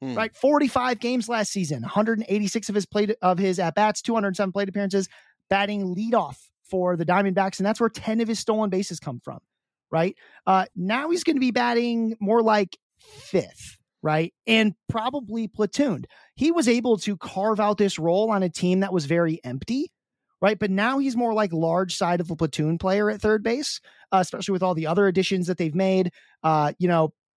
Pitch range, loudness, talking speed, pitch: 180-225 Hz, -24 LUFS, 215 wpm, 200 Hz